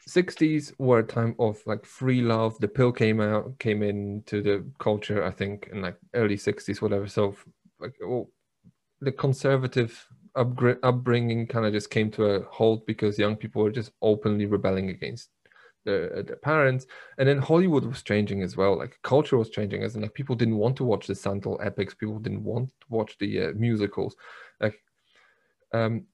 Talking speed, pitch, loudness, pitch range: 185 wpm, 110 Hz, -26 LUFS, 105-125 Hz